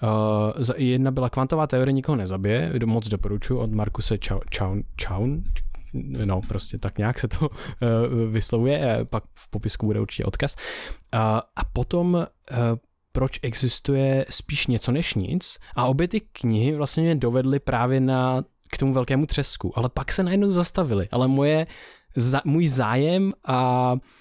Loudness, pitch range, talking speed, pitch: -24 LUFS, 110-140 Hz, 165 wpm, 125 Hz